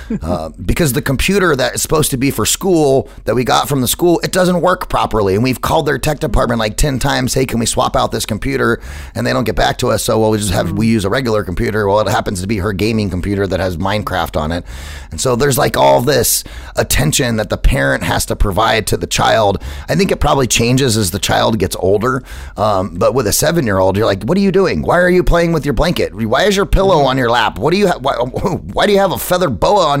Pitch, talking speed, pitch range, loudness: 115 Hz, 265 wpm, 100-150 Hz, -14 LUFS